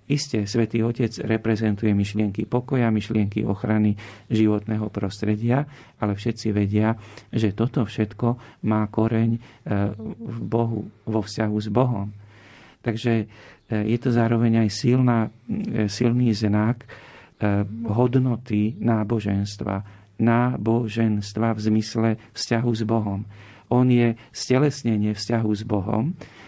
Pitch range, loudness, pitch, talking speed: 105-115 Hz, -23 LUFS, 110 Hz, 105 wpm